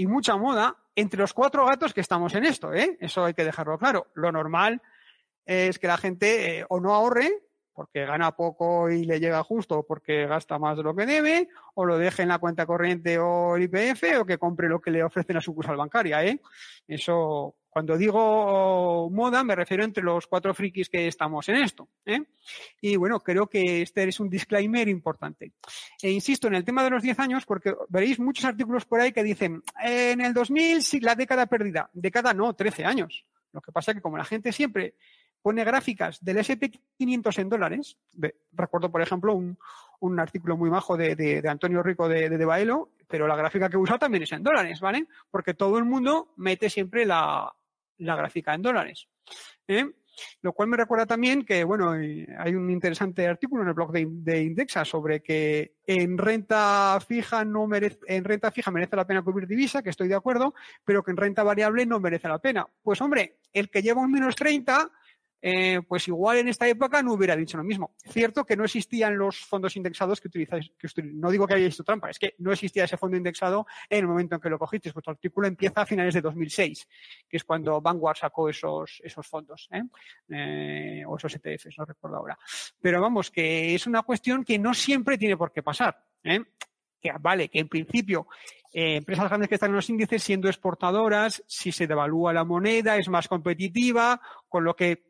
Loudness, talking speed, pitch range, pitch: -25 LUFS, 205 wpm, 170-225 Hz, 195 Hz